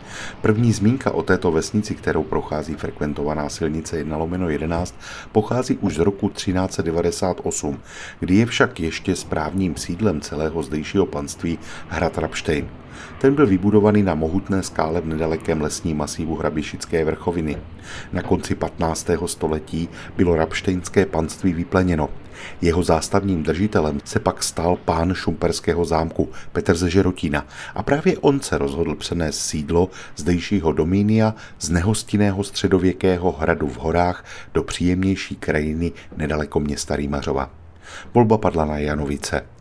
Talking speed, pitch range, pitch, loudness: 130 wpm, 80-100 Hz, 85 Hz, -21 LUFS